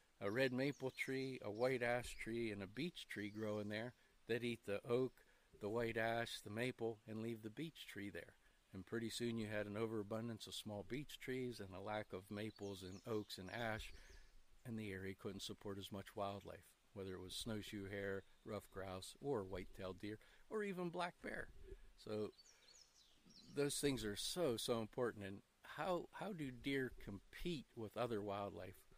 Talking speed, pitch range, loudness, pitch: 180 wpm, 100-125 Hz, -47 LUFS, 110 Hz